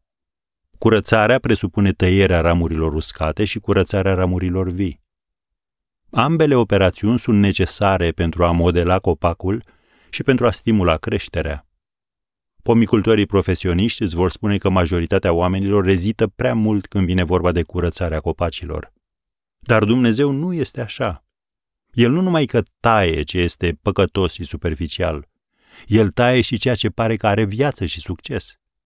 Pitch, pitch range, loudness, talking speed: 95 Hz, 85-110 Hz, -18 LUFS, 135 wpm